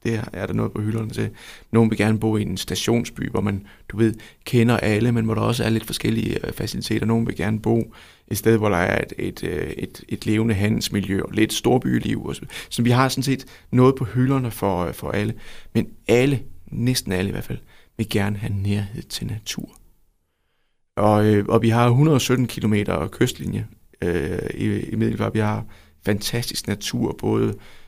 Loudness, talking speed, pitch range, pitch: -22 LUFS, 190 wpm, 100-115 Hz, 110 Hz